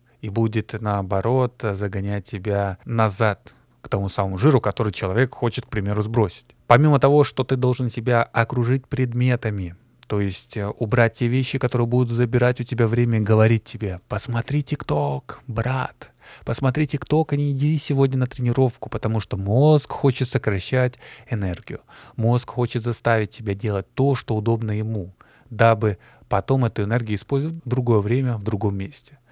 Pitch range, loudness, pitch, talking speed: 105-130 Hz, -22 LUFS, 120 Hz, 155 wpm